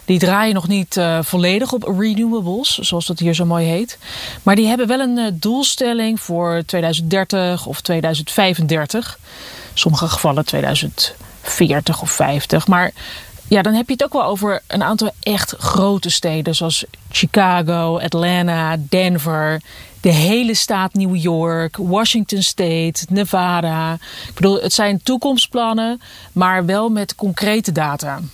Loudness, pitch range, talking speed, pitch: -16 LUFS, 170-210 Hz, 140 wpm, 185 Hz